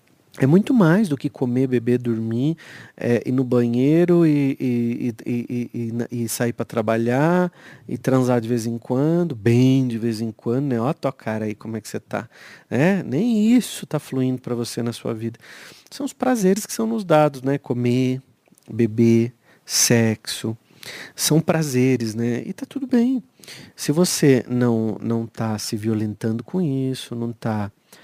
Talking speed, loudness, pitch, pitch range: 175 wpm, -21 LUFS, 125 Hz, 115-155 Hz